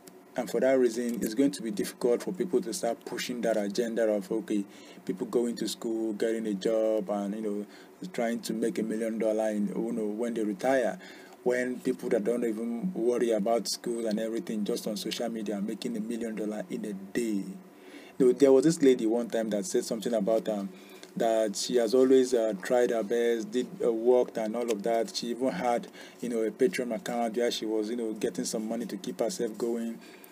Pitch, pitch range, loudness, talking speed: 115 Hz, 110-120 Hz, -29 LUFS, 215 wpm